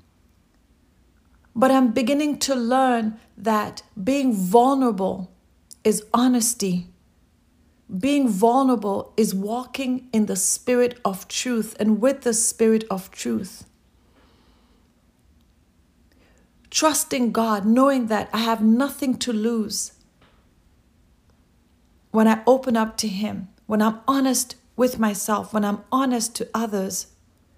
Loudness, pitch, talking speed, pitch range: -21 LUFS, 225 Hz, 110 wpm, 205-250 Hz